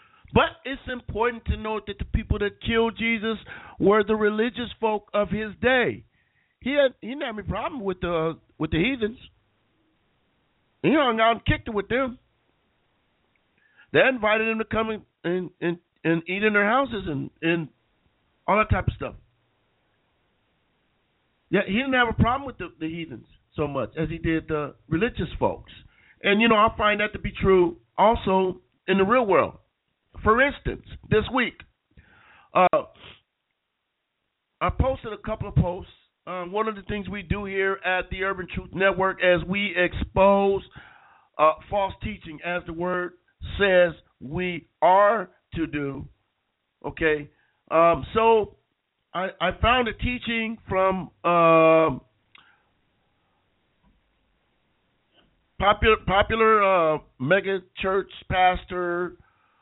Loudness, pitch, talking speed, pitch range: -24 LUFS, 195 Hz, 145 wpm, 170-220 Hz